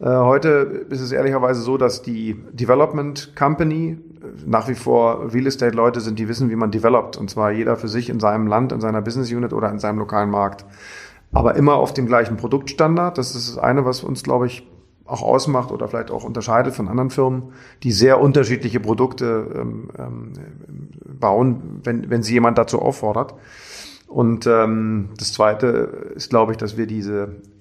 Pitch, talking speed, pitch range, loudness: 120 Hz, 170 wpm, 110-130 Hz, -19 LUFS